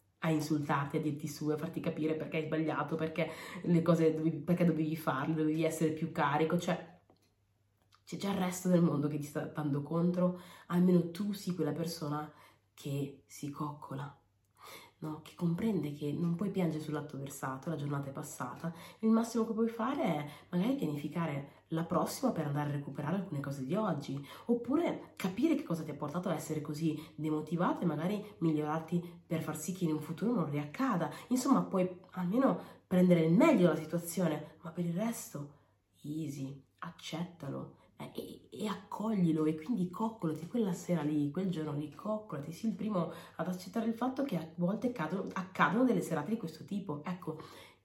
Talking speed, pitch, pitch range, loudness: 180 wpm, 160 Hz, 150-185 Hz, -35 LUFS